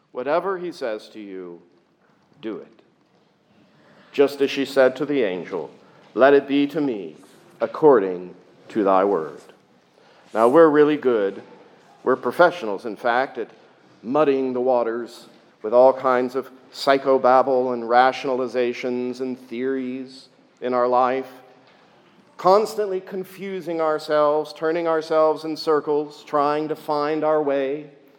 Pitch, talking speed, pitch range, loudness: 135 Hz, 125 wpm, 125-155 Hz, -21 LUFS